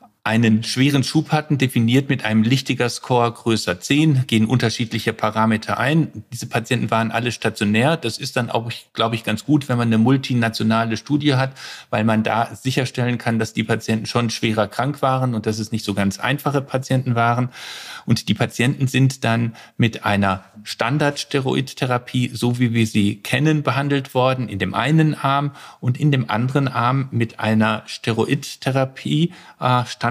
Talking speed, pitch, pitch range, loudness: 165 wpm, 120 Hz, 110-135 Hz, -20 LUFS